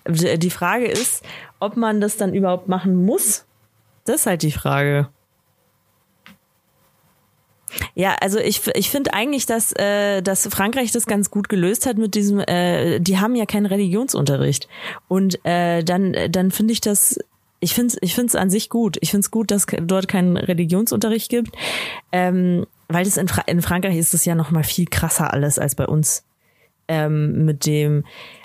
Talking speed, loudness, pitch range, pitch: 175 wpm, -19 LUFS, 170-210 Hz, 190 Hz